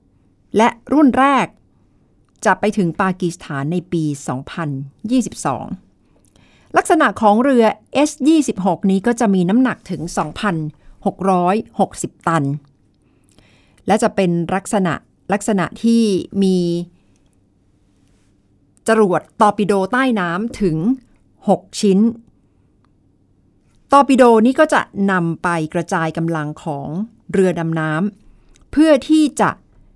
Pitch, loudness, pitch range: 190 Hz, -17 LUFS, 155-225 Hz